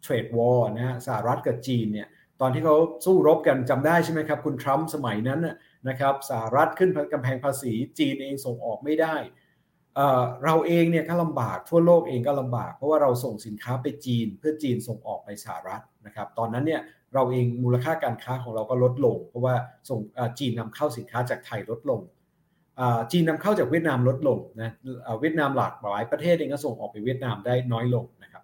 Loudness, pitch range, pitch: -25 LUFS, 120-155 Hz, 130 Hz